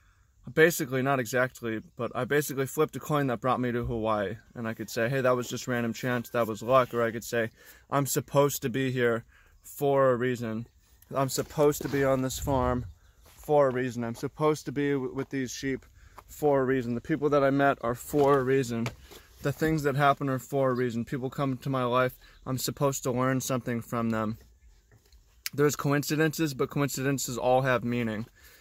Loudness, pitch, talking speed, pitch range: -28 LUFS, 130 Hz, 200 wpm, 115-140 Hz